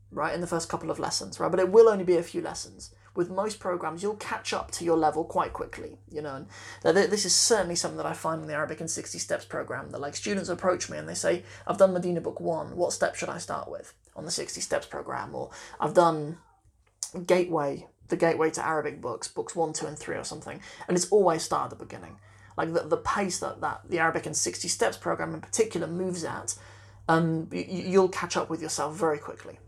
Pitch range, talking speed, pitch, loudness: 155-185 Hz, 235 wpm, 170 Hz, -28 LUFS